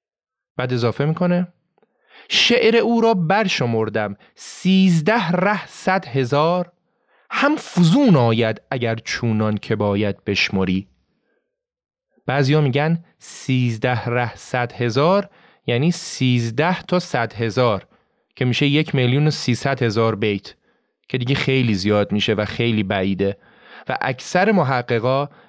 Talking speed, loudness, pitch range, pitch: 120 wpm, -19 LUFS, 115-180 Hz, 135 Hz